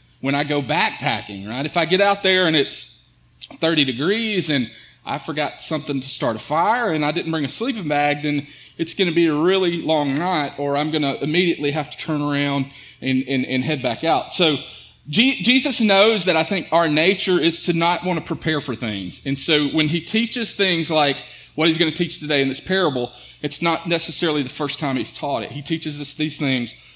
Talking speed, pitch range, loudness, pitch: 225 wpm, 140-170 Hz, -20 LUFS, 155 Hz